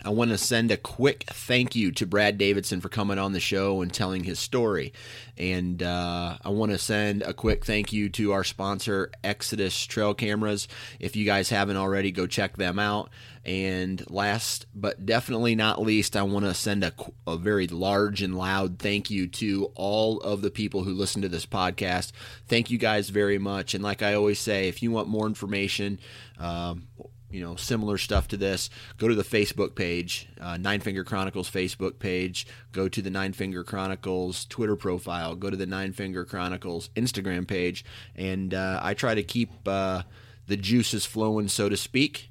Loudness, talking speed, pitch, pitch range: -27 LUFS, 190 wpm, 100 Hz, 95-110 Hz